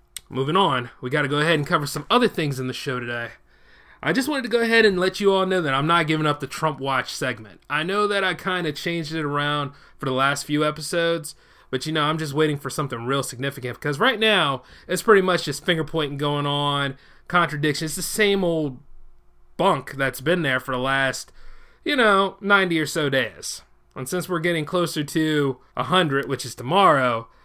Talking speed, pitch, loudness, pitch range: 215 wpm, 150 Hz, -22 LUFS, 135-180 Hz